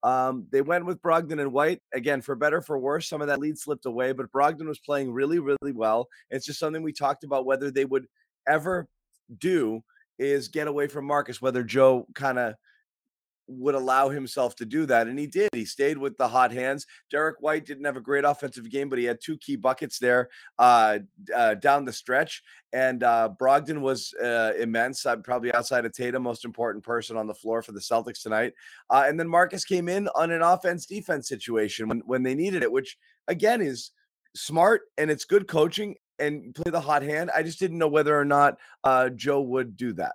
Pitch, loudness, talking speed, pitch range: 140 Hz, -26 LUFS, 210 wpm, 125-155 Hz